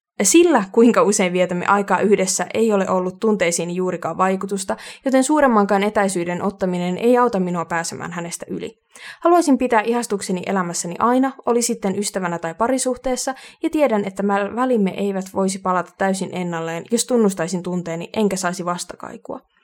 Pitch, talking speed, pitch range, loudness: 195 Hz, 145 wpm, 180-235 Hz, -19 LUFS